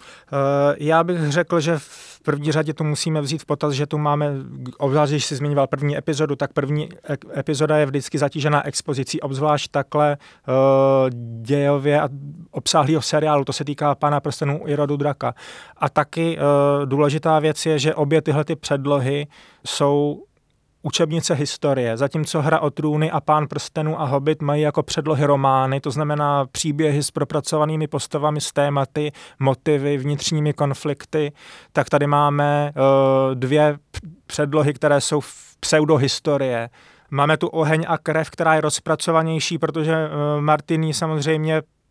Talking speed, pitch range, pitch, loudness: 150 wpm, 145-155 Hz, 150 Hz, -20 LUFS